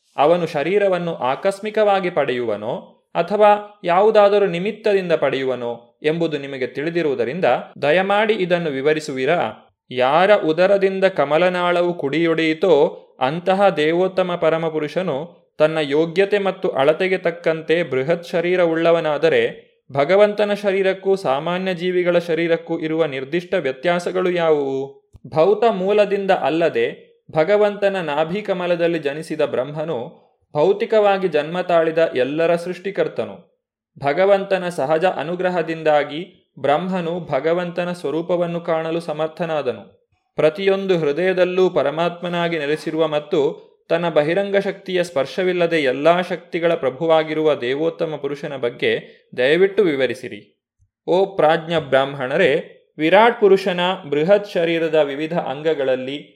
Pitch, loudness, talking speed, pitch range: 170 Hz, -19 LUFS, 90 wpm, 155-195 Hz